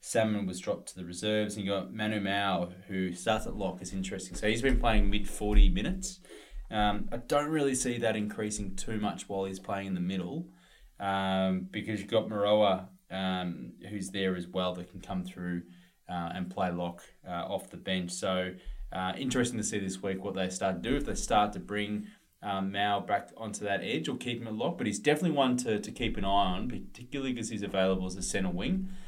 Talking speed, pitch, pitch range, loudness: 220 wpm, 100 Hz, 95-110 Hz, -32 LUFS